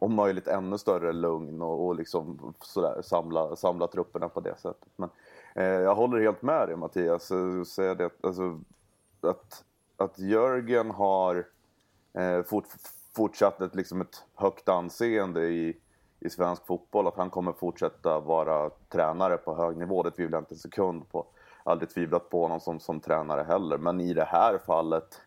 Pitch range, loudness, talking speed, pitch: 85-95 Hz, -29 LUFS, 170 wpm, 90 Hz